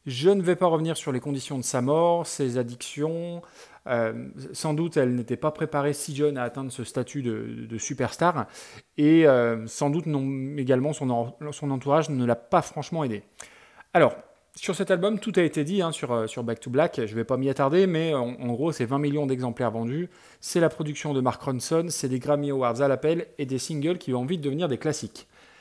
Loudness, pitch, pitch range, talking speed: -26 LUFS, 145 Hz, 125-160 Hz, 220 wpm